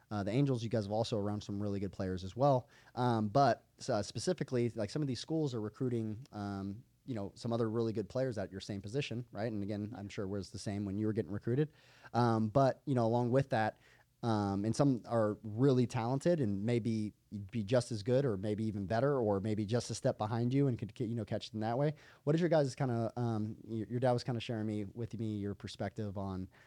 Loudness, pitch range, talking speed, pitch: -35 LUFS, 105-125 Hz, 245 wpm, 115 Hz